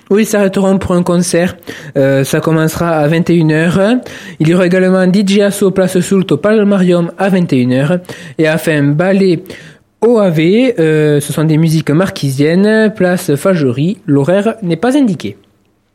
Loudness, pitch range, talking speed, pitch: -11 LUFS, 155-195 Hz, 145 wpm, 175 Hz